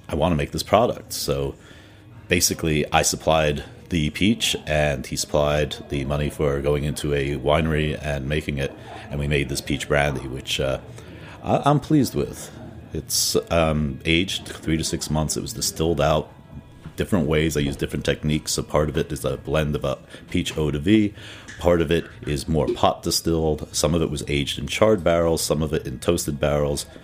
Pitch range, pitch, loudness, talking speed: 70-85 Hz, 75 Hz, -22 LUFS, 195 wpm